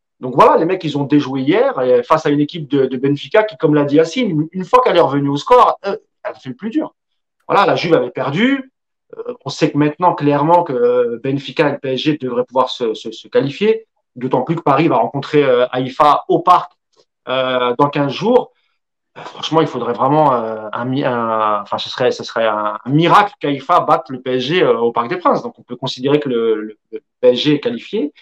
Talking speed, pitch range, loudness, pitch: 225 wpm, 130-170 Hz, -15 LUFS, 145 Hz